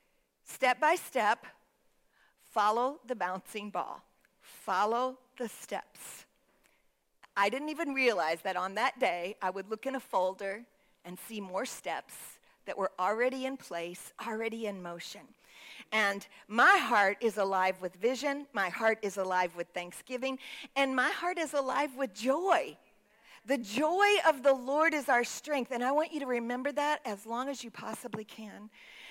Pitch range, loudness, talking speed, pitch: 200-270 Hz, -32 LUFS, 160 wpm, 235 Hz